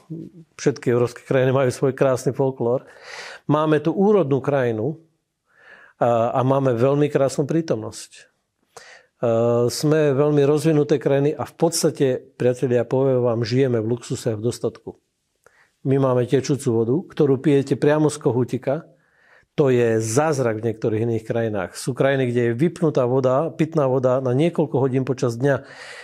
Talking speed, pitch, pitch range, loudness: 145 wpm, 135 Hz, 125-155 Hz, -20 LUFS